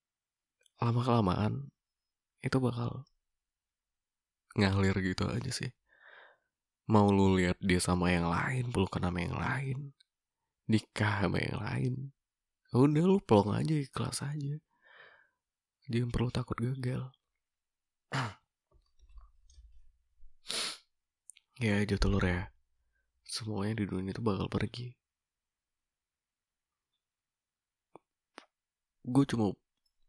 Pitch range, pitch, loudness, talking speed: 90-125 Hz, 105 Hz, -32 LUFS, 90 wpm